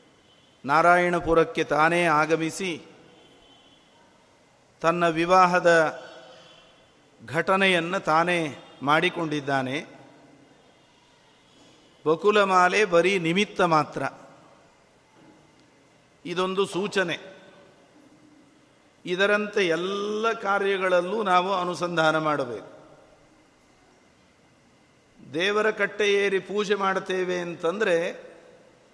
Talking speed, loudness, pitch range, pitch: 55 wpm, -23 LUFS, 160-195 Hz, 175 Hz